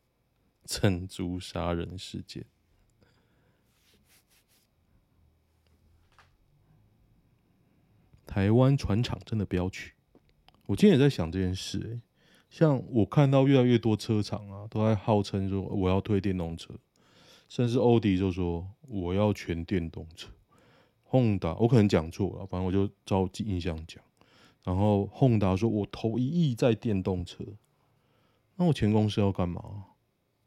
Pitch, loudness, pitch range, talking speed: 105 Hz, -28 LUFS, 95-115 Hz, 190 characters per minute